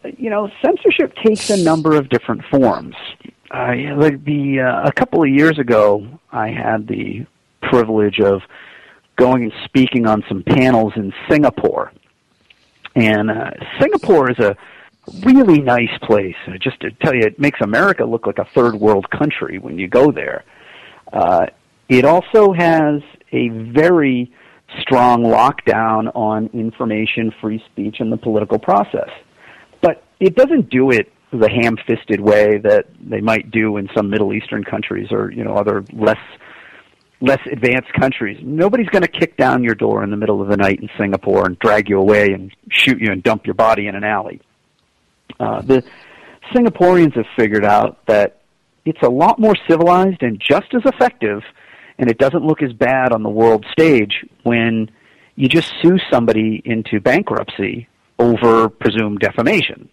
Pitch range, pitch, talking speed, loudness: 110-150 Hz, 120 Hz, 160 wpm, -15 LUFS